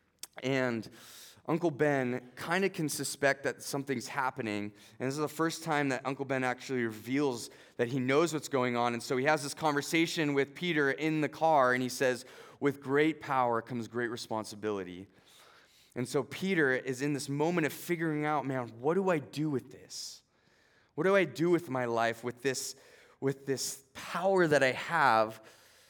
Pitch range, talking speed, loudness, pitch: 125-150 Hz, 185 wpm, -32 LUFS, 135 Hz